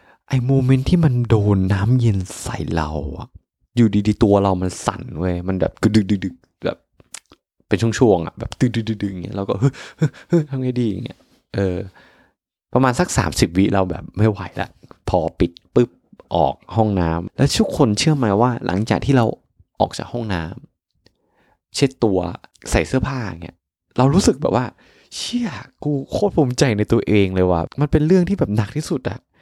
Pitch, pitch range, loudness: 115 Hz, 95-135 Hz, -19 LUFS